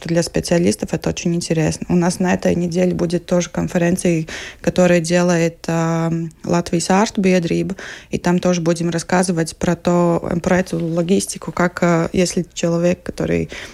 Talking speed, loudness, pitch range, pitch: 150 wpm, -18 LUFS, 170-180 Hz, 175 Hz